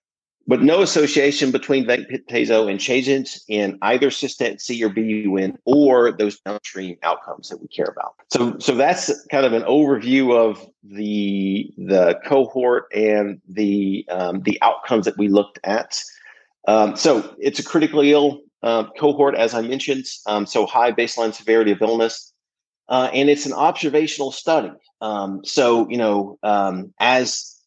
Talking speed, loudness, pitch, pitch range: 155 wpm, -19 LUFS, 115 Hz, 105-140 Hz